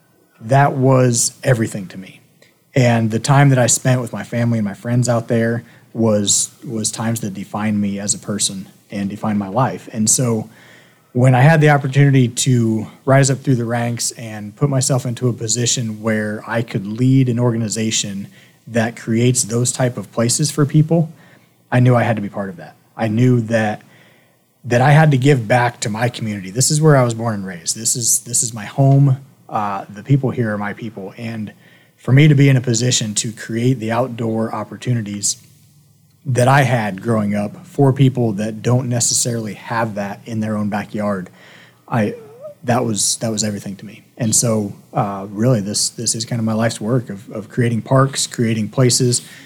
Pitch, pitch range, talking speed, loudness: 120 Hz, 110-130 Hz, 195 wpm, -17 LUFS